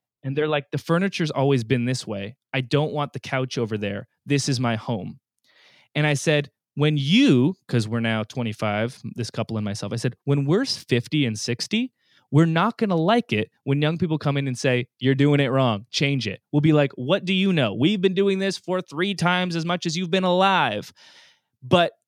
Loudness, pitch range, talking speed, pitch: -23 LUFS, 125-170 Hz, 215 wpm, 140 Hz